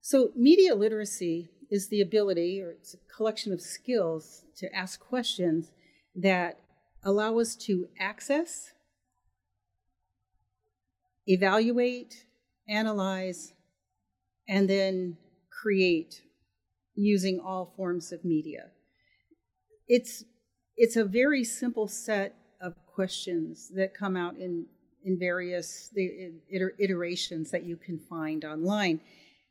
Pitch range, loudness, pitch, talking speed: 170-215 Hz, -29 LUFS, 190 Hz, 105 wpm